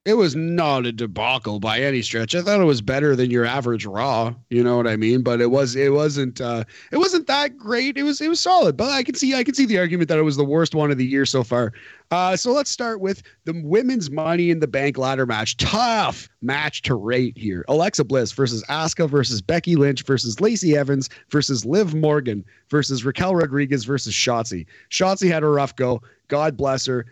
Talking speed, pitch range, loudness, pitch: 225 wpm, 125-175 Hz, -20 LUFS, 140 Hz